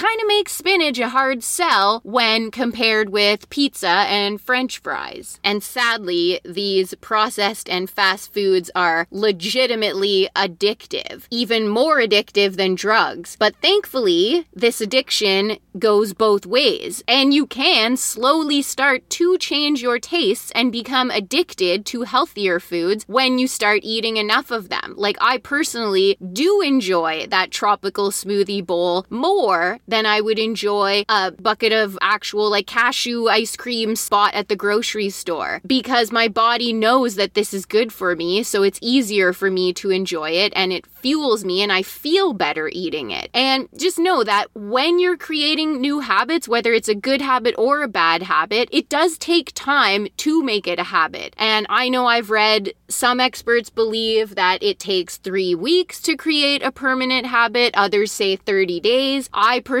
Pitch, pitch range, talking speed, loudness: 225 Hz, 200-265 Hz, 165 wpm, -18 LUFS